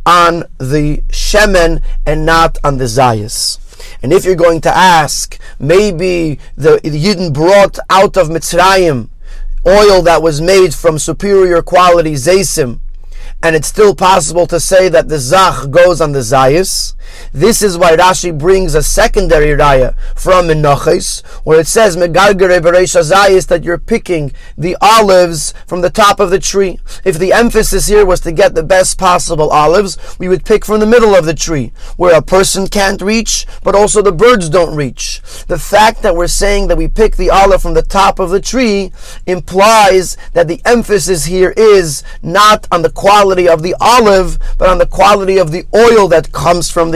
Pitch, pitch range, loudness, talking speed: 180 Hz, 165-195 Hz, -9 LUFS, 175 wpm